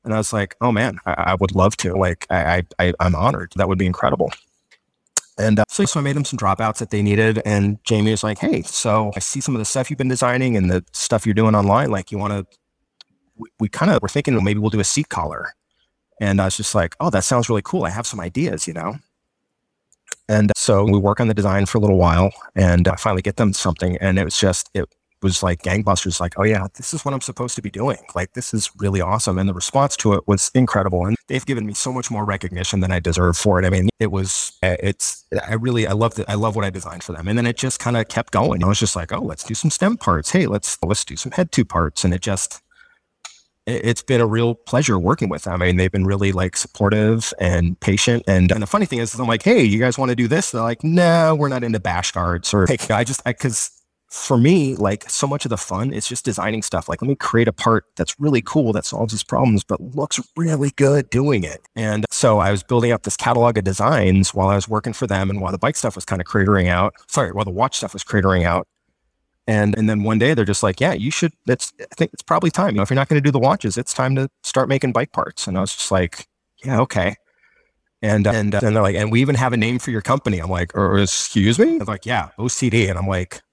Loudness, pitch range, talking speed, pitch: -19 LUFS, 95-120 Hz, 270 wpm, 105 Hz